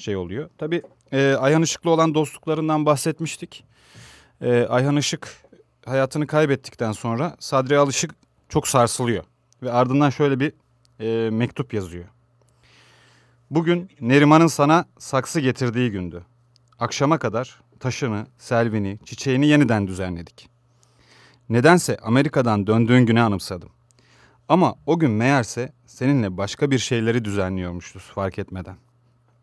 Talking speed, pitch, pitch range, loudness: 110 wpm, 125 Hz, 115-145 Hz, -21 LUFS